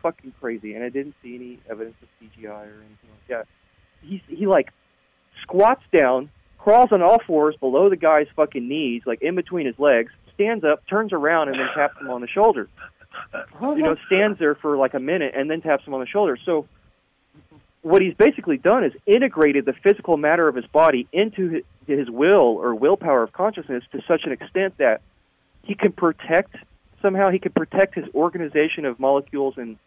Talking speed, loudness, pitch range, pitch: 195 wpm, -20 LUFS, 130-190 Hz, 150 Hz